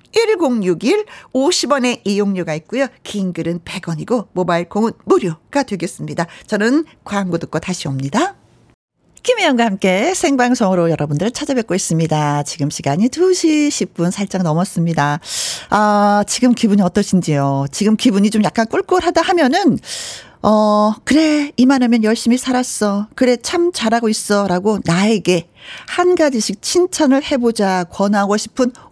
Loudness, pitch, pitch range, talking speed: -16 LUFS, 215 Hz, 180-270 Hz, 300 characters per minute